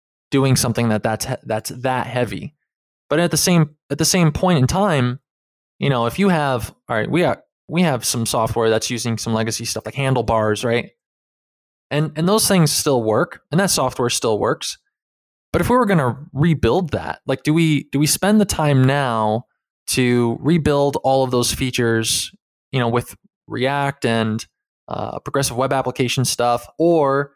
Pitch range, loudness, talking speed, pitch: 115-150 Hz, -19 LUFS, 180 wpm, 130 Hz